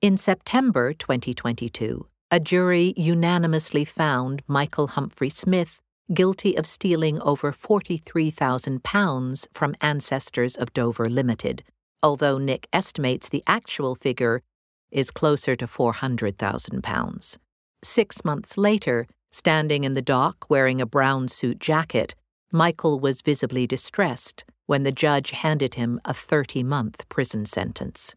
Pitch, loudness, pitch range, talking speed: 140 Hz, -24 LUFS, 125-165 Hz, 115 wpm